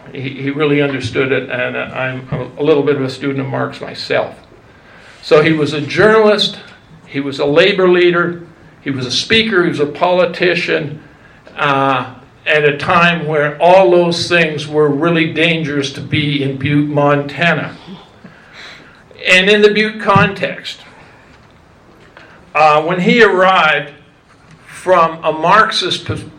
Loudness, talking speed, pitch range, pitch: -13 LUFS, 140 wpm, 145-175 Hz, 155 Hz